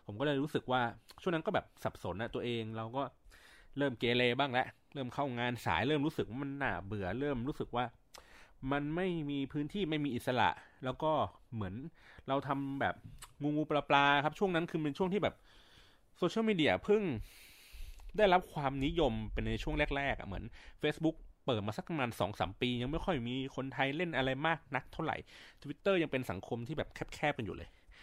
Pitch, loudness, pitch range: 135 Hz, -35 LUFS, 120-150 Hz